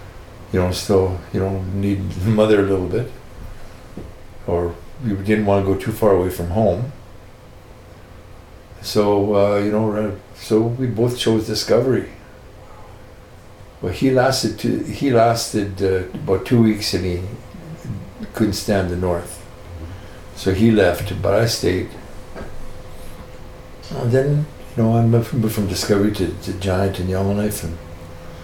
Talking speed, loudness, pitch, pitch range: 145 wpm, -19 LUFS, 100 Hz, 90-110 Hz